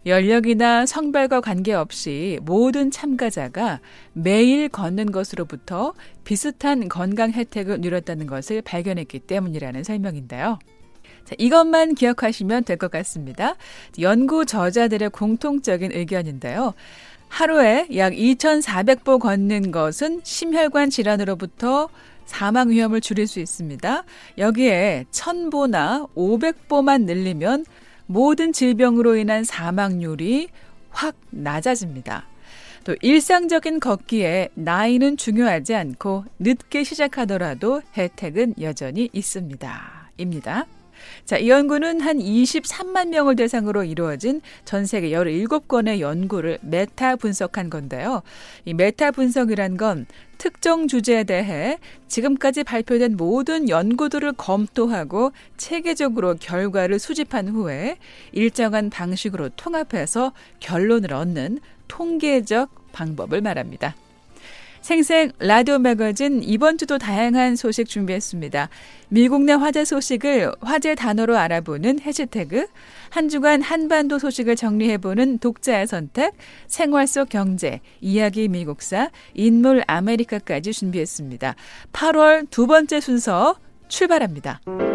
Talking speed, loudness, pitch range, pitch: 270 characters per minute, -20 LUFS, 190-280 Hz, 230 Hz